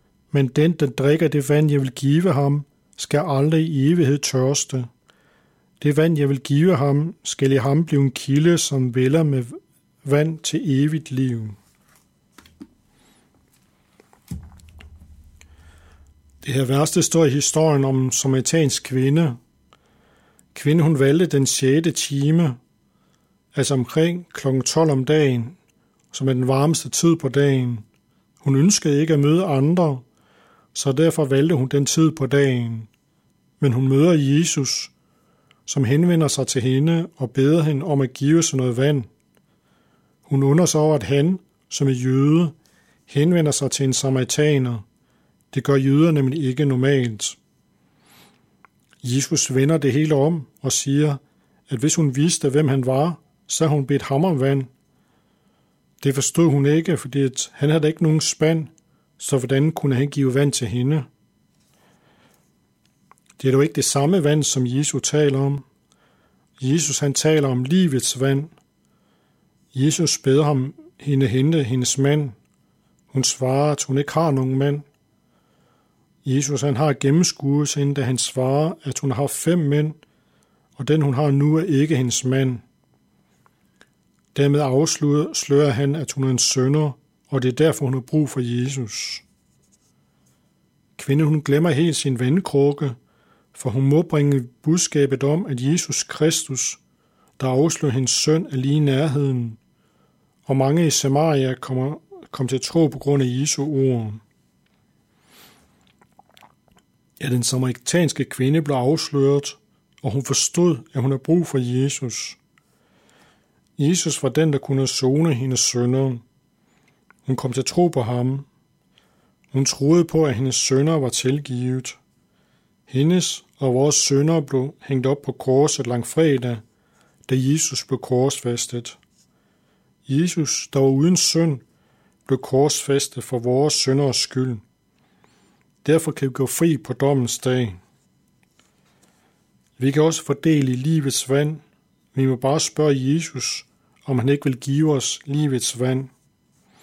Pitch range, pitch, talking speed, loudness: 130-150 Hz, 140 Hz, 145 wpm, -20 LUFS